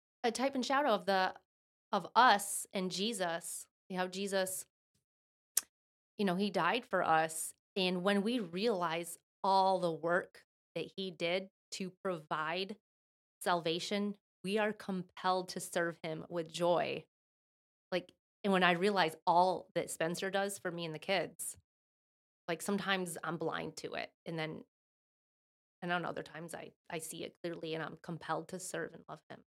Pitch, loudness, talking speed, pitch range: 185 Hz, -36 LUFS, 160 wpm, 170-195 Hz